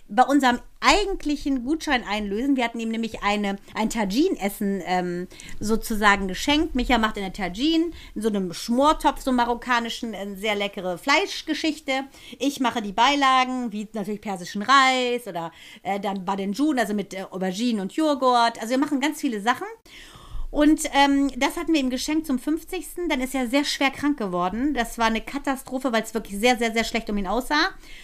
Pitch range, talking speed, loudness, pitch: 210-285 Hz, 180 wpm, -23 LUFS, 245 Hz